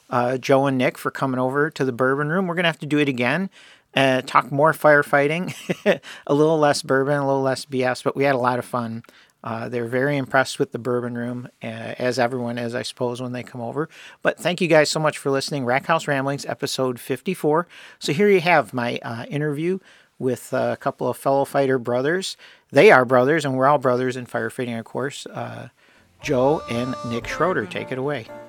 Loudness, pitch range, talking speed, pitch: -21 LUFS, 125-145 Hz, 215 wpm, 135 Hz